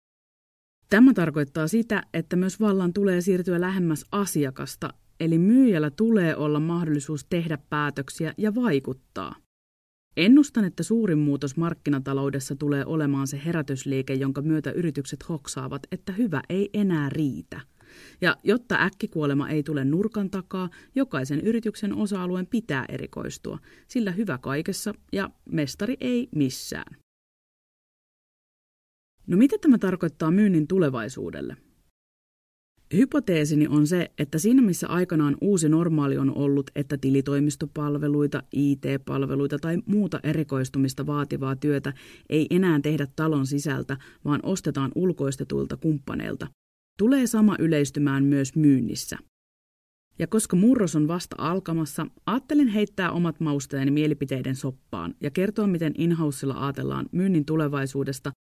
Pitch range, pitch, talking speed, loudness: 140-190 Hz, 155 Hz, 115 wpm, -25 LUFS